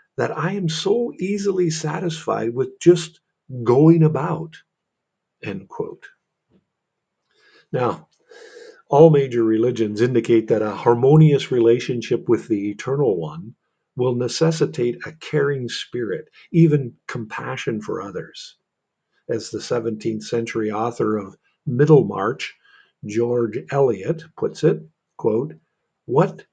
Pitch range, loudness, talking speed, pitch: 115-170 Hz, -20 LUFS, 105 wpm, 140 Hz